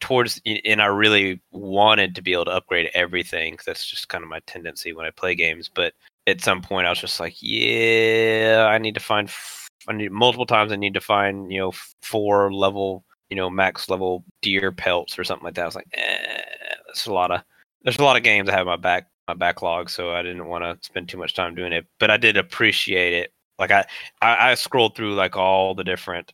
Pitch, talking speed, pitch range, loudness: 100 Hz, 235 wpm, 95-110 Hz, -20 LUFS